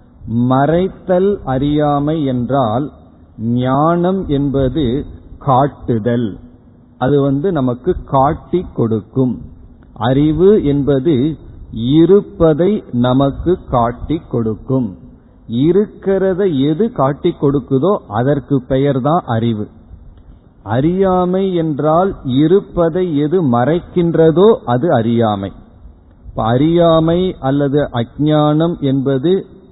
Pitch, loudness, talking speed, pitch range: 140 Hz, -14 LUFS, 75 wpm, 120-170 Hz